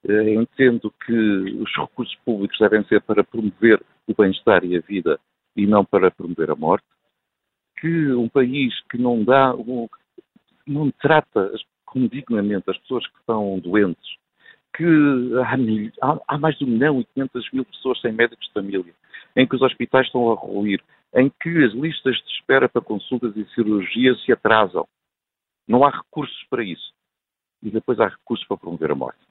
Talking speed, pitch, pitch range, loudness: 170 wpm, 120 Hz, 105-130 Hz, -20 LUFS